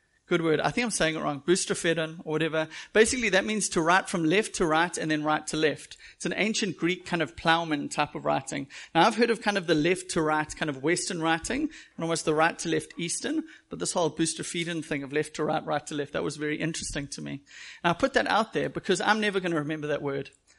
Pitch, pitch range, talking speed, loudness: 165 Hz, 155-190 Hz, 255 wpm, -27 LUFS